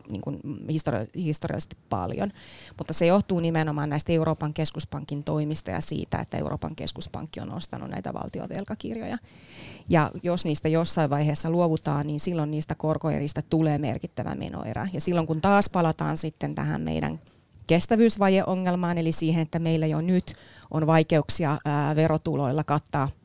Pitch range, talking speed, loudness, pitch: 150-170 Hz, 140 wpm, -25 LUFS, 160 Hz